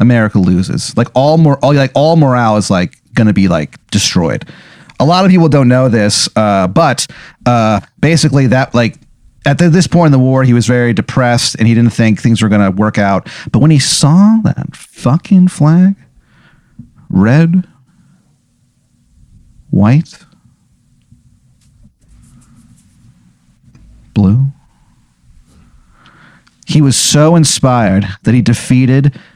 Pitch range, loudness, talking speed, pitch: 115-150 Hz, -10 LUFS, 135 wpm, 125 Hz